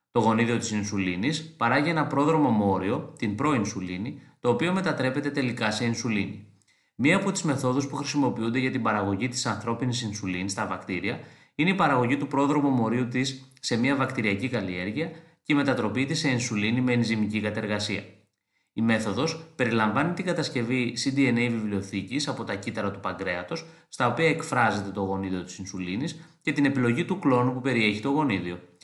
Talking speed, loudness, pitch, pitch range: 160 wpm, -26 LUFS, 120 Hz, 105-140 Hz